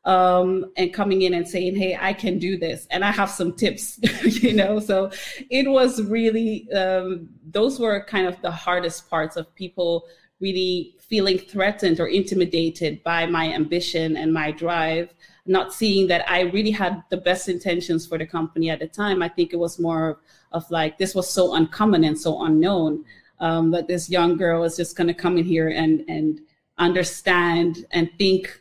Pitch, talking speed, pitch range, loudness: 180 Hz, 190 wpm, 165-190 Hz, -22 LUFS